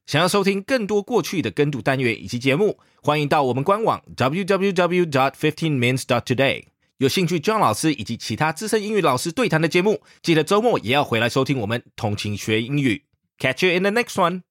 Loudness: -21 LUFS